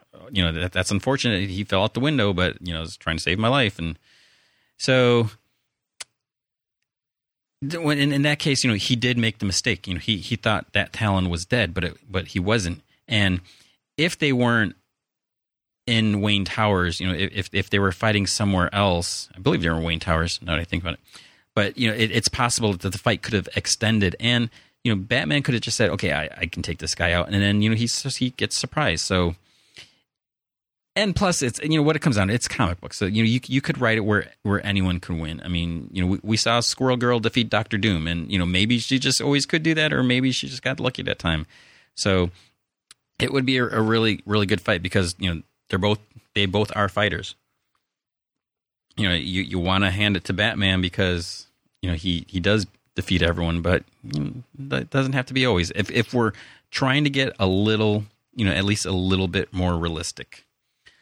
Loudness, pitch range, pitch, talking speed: -22 LUFS, 90-120 Hz, 105 Hz, 225 wpm